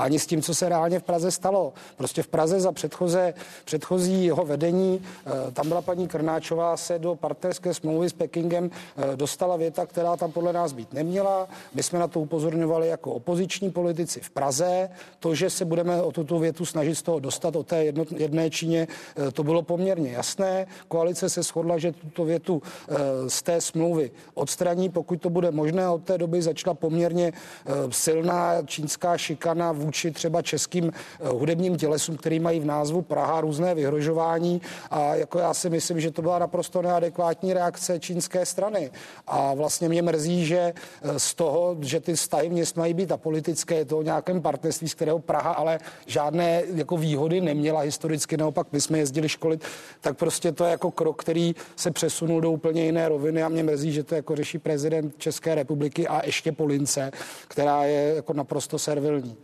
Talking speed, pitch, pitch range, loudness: 180 wpm, 165 Hz, 155-175 Hz, -26 LUFS